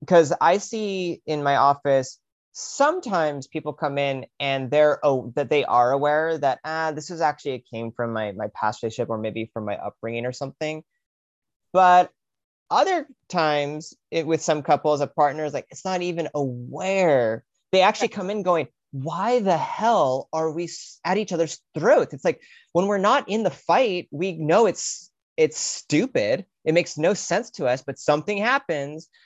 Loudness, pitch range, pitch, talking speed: -23 LUFS, 140-185 Hz, 155 Hz, 175 wpm